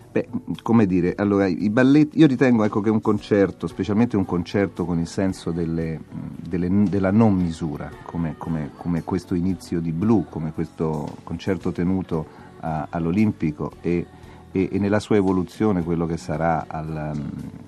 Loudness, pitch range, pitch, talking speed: -22 LUFS, 85-100 Hz, 90 Hz, 160 wpm